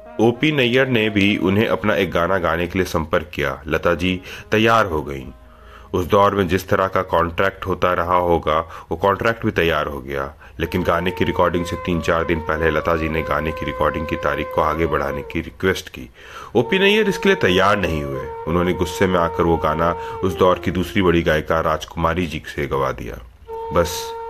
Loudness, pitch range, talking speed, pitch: -19 LUFS, 80-100 Hz, 205 wpm, 90 Hz